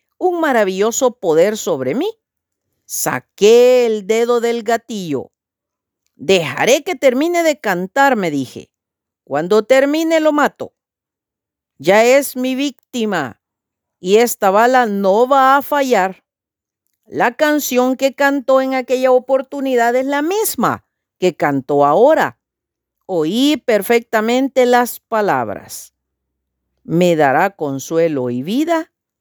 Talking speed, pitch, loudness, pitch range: 110 wpm, 240 Hz, -15 LUFS, 185-275 Hz